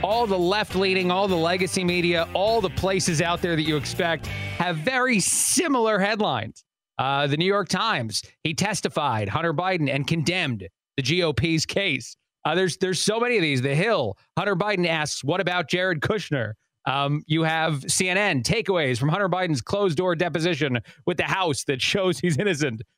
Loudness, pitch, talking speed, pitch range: -23 LUFS, 175 Hz, 180 wpm, 150-190 Hz